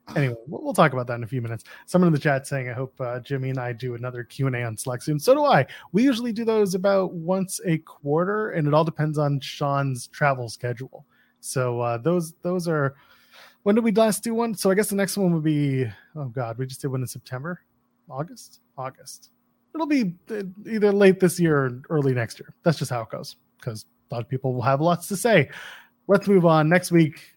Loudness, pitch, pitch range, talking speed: -23 LUFS, 150 Hz, 130-190 Hz, 230 wpm